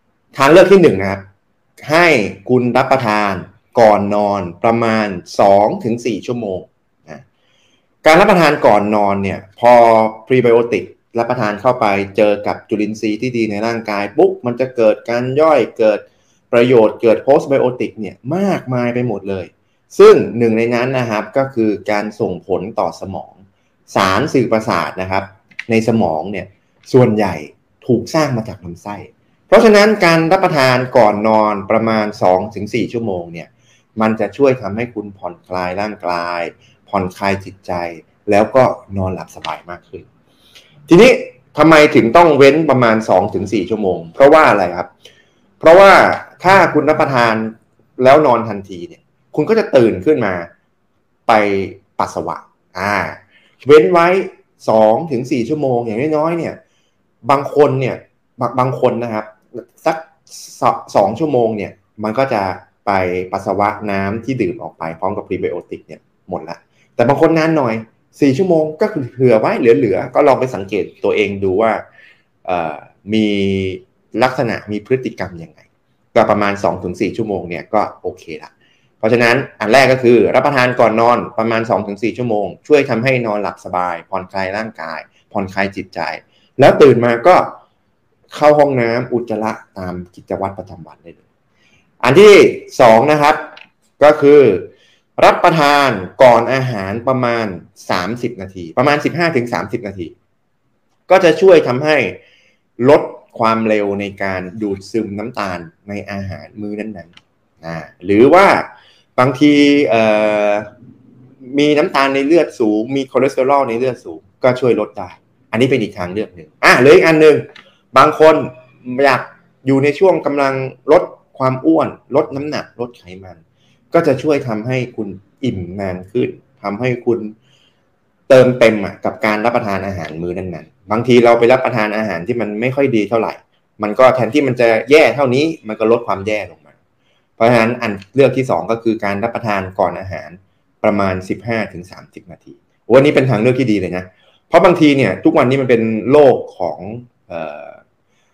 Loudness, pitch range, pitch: -13 LUFS, 100-135 Hz, 115 Hz